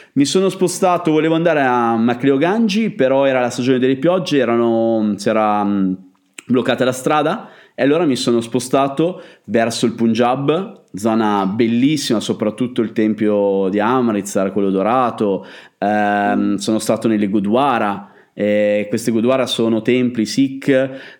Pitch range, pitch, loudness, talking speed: 105-135 Hz, 120 Hz, -16 LUFS, 130 wpm